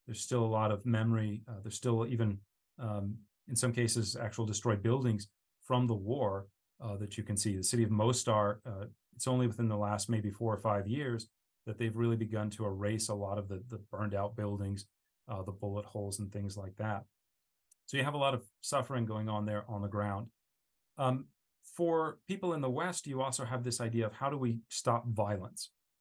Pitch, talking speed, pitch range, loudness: 110 Hz, 210 wpm, 105-120 Hz, -35 LUFS